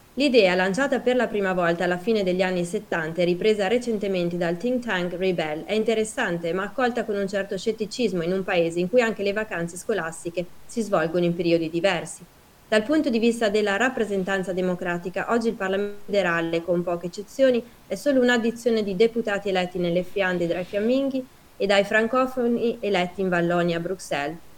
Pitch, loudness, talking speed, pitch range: 195 Hz, -24 LUFS, 175 wpm, 180-230 Hz